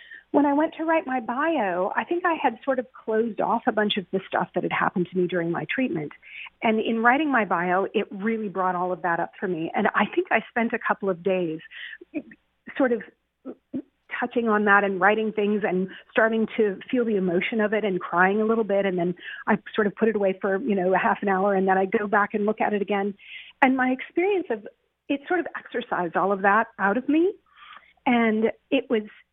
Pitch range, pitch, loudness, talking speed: 195-260 Hz, 220 Hz, -24 LUFS, 235 wpm